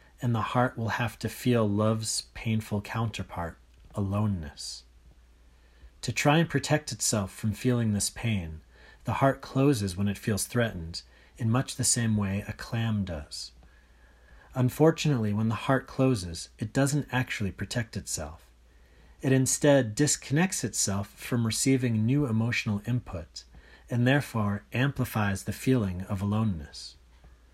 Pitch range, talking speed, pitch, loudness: 80-125 Hz, 135 wpm, 105 Hz, -28 LUFS